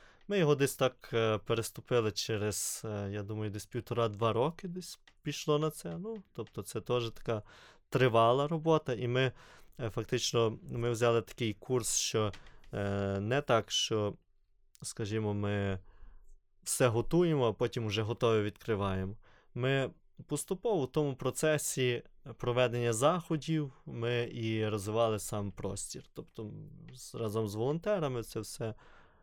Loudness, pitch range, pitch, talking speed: -33 LUFS, 110-135 Hz, 115 Hz, 125 wpm